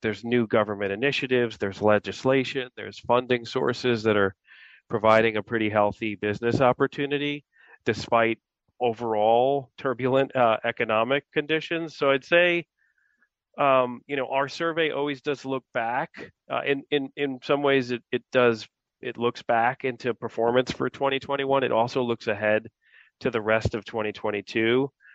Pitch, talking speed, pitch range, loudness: 125 Hz, 145 wpm, 110-140 Hz, -25 LUFS